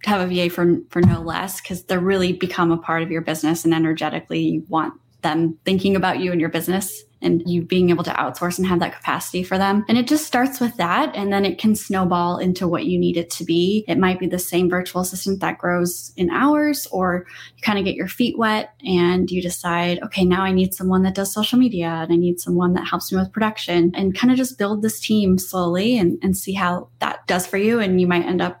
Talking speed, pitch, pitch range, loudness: 250 wpm, 180 Hz, 175-195 Hz, -20 LUFS